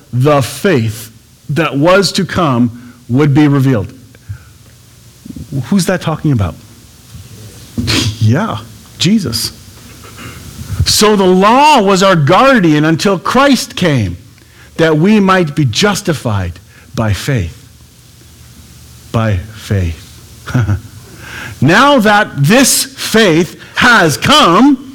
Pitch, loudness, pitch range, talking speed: 125 Hz, -10 LUFS, 115-180 Hz, 95 wpm